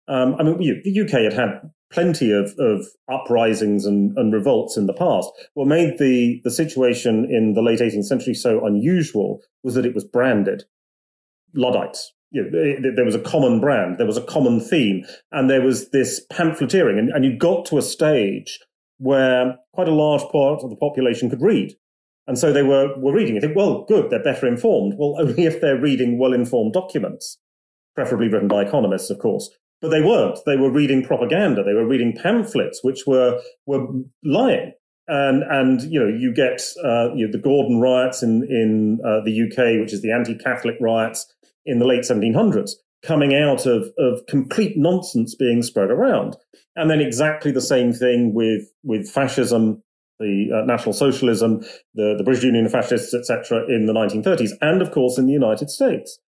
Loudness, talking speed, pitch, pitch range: -19 LUFS, 190 wpm, 130 Hz, 115-150 Hz